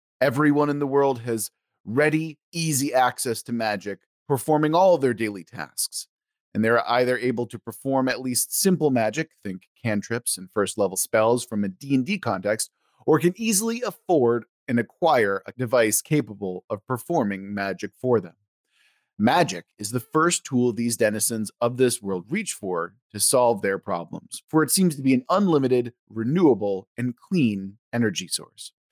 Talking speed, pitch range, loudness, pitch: 165 wpm, 105-145 Hz, -23 LUFS, 120 Hz